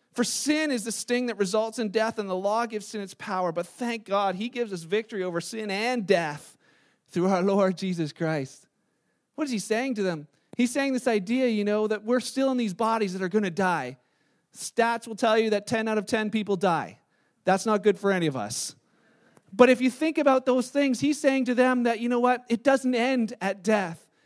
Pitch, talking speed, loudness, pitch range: 220 Hz, 230 wpm, -26 LUFS, 195-245 Hz